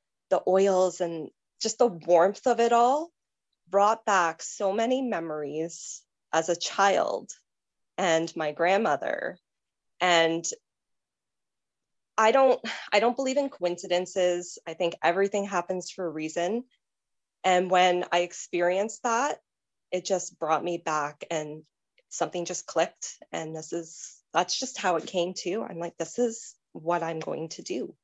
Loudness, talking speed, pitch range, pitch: -27 LUFS, 145 wpm, 170-205 Hz, 180 Hz